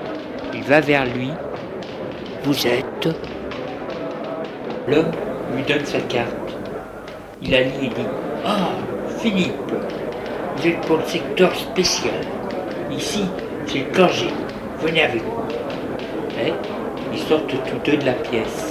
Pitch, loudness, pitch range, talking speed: 145 Hz, -22 LUFS, 130-165 Hz, 125 wpm